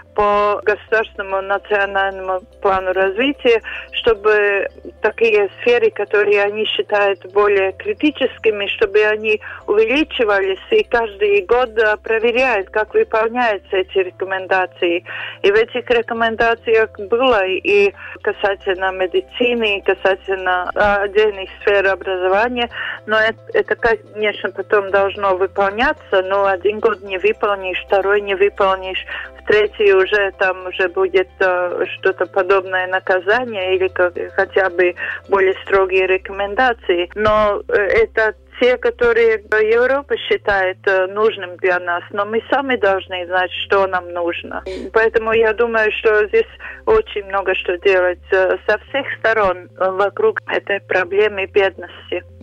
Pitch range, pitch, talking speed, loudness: 190-235 Hz, 205 Hz, 120 wpm, -17 LUFS